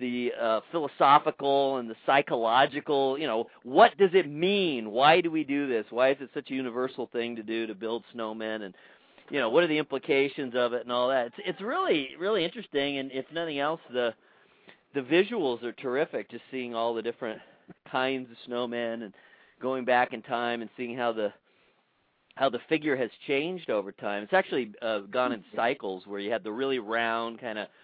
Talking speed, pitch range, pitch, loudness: 195 wpm, 115-140 Hz, 125 Hz, -28 LUFS